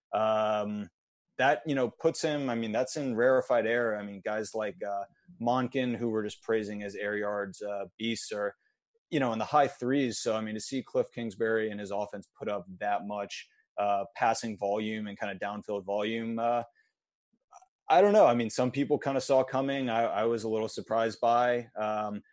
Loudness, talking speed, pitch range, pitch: -30 LUFS, 205 wpm, 105-130 Hz, 110 Hz